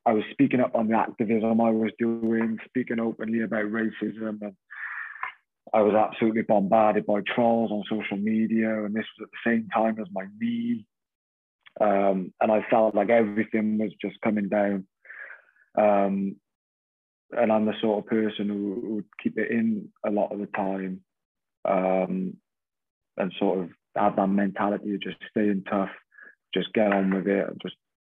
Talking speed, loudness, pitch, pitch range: 170 wpm, -26 LUFS, 110 Hz, 100-115 Hz